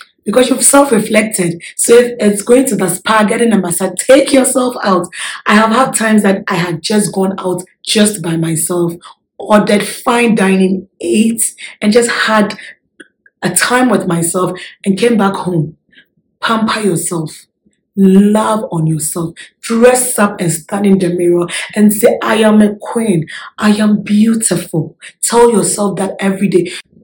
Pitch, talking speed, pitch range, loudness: 205 Hz, 160 wpm, 180-220 Hz, -11 LUFS